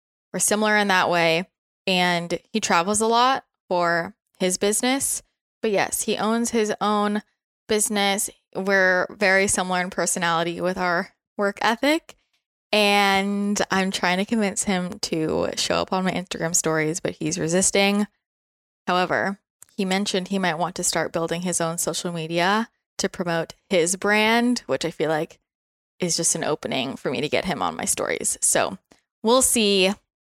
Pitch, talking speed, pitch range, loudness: 190 Hz, 160 wpm, 175-210 Hz, -22 LUFS